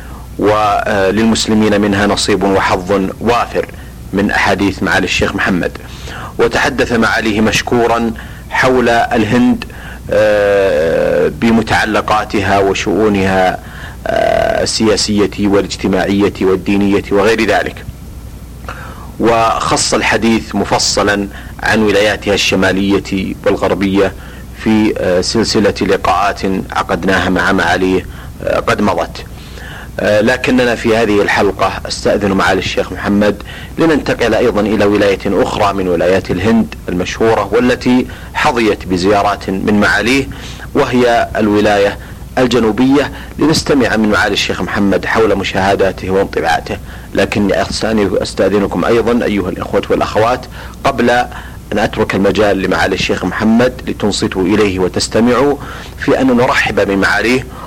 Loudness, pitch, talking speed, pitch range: -12 LUFS, 105 Hz, 100 wpm, 95-115 Hz